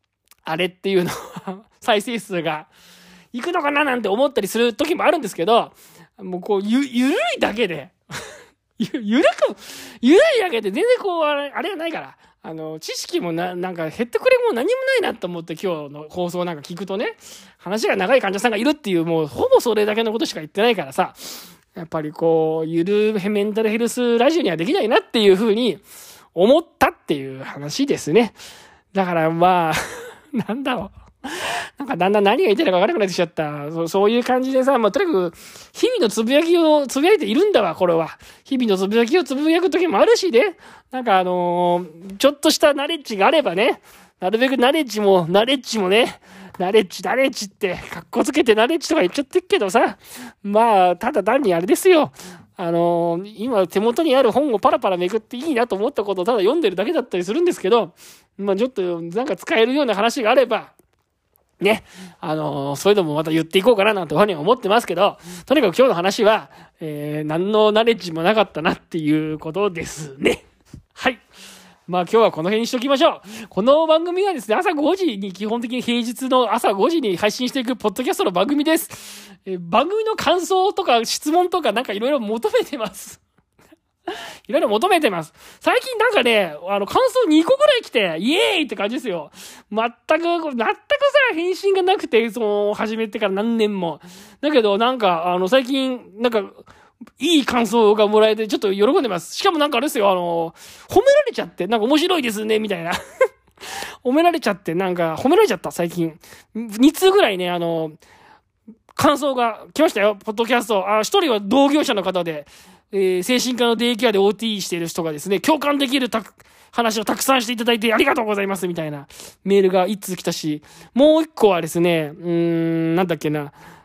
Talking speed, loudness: 400 characters per minute, -19 LUFS